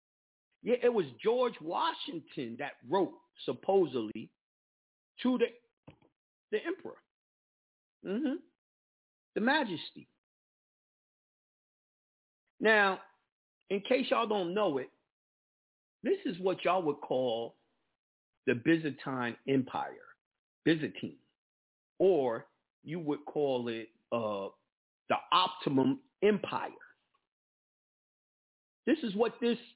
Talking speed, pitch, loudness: 90 wpm, 220 Hz, -33 LUFS